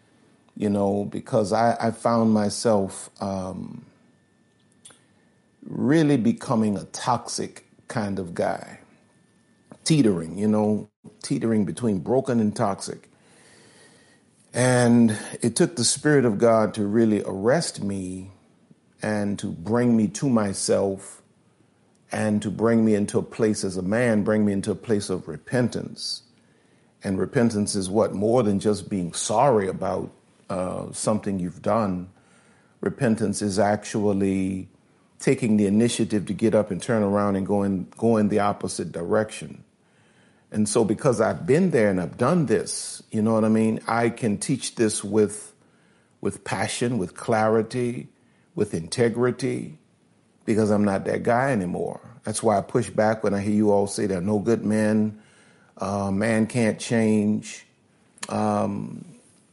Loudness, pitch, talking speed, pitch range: -23 LUFS, 105 Hz, 145 wpm, 100-115 Hz